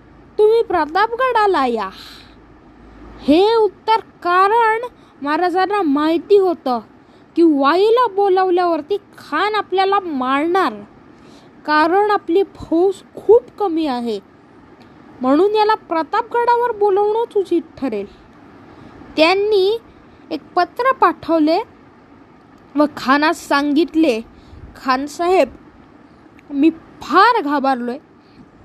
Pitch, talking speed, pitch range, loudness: 345 Hz, 80 wpm, 295-410 Hz, -16 LUFS